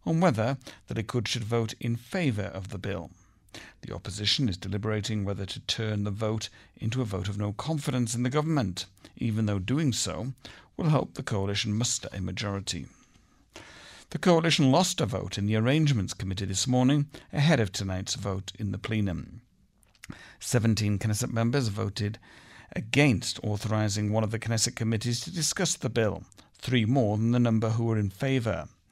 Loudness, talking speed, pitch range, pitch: -28 LUFS, 170 wpm, 100-130 Hz, 110 Hz